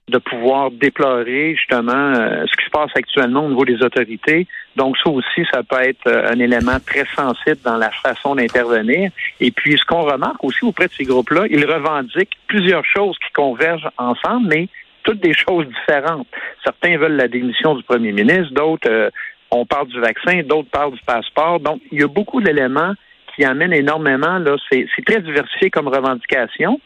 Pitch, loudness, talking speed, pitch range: 145 Hz, -16 LUFS, 190 wpm, 130-170 Hz